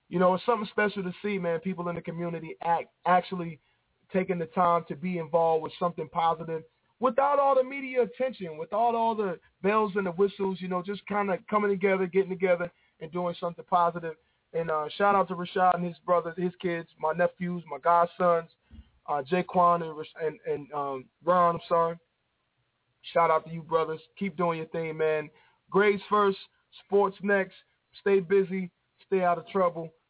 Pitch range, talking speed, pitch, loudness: 165-195 Hz, 185 wpm, 175 Hz, -28 LUFS